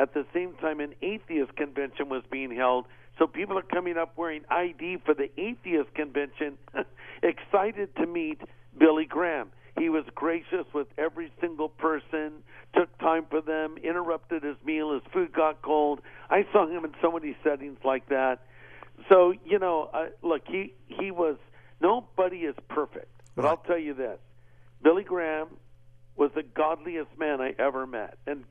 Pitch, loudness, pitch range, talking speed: 155 Hz, -28 LUFS, 140-170 Hz, 165 wpm